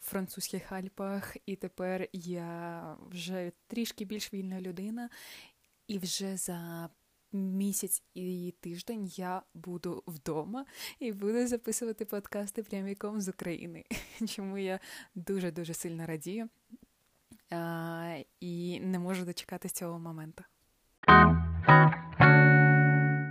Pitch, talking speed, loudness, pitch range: 185 Hz, 100 wpm, -29 LUFS, 170-200 Hz